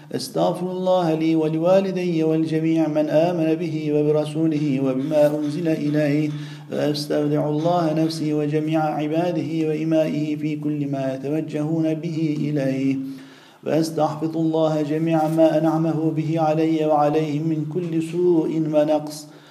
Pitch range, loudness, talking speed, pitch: 150-160 Hz, -21 LUFS, 110 wpm, 155 Hz